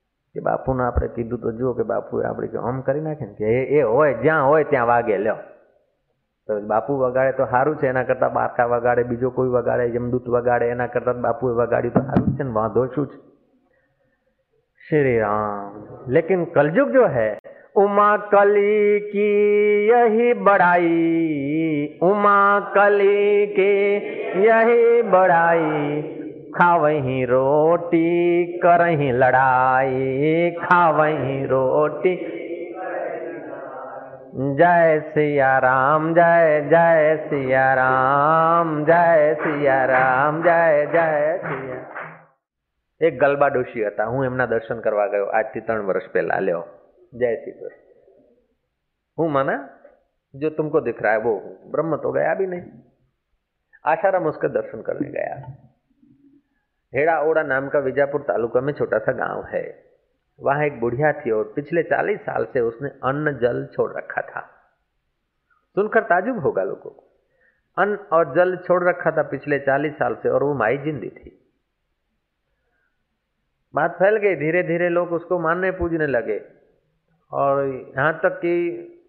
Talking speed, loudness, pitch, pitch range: 130 wpm, -19 LUFS, 160 Hz, 130-195 Hz